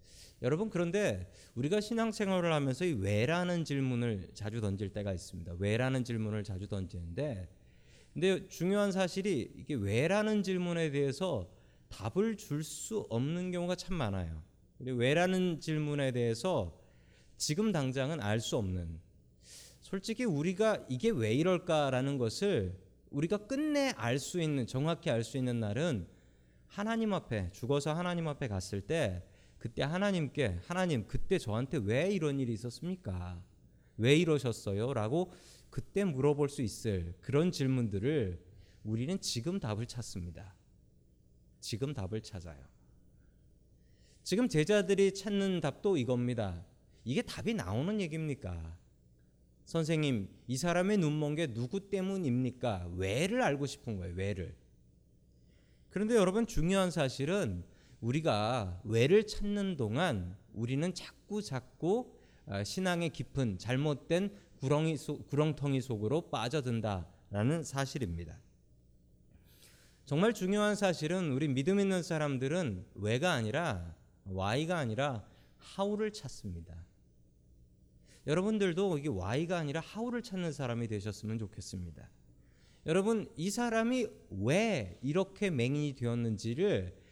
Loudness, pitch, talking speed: -34 LUFS, 130 Hz, 285 characters per minute